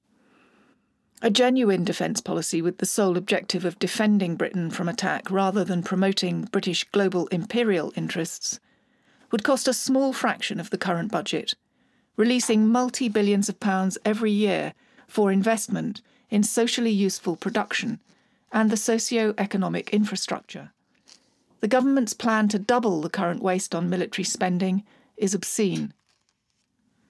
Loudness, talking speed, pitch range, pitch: -24 LUFS, 135 wpm, 185-230 Hz, 205 Hz